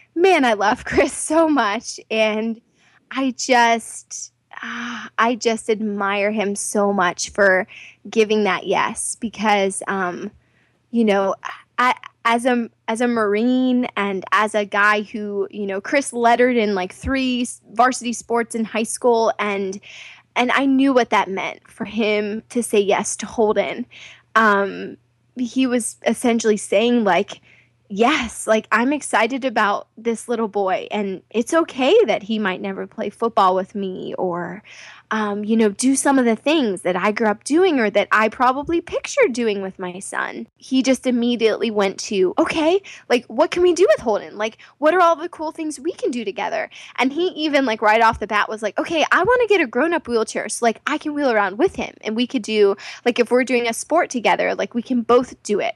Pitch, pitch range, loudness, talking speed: 230 Hz, 205-260 Hz, -19 LUFS, 190 wpm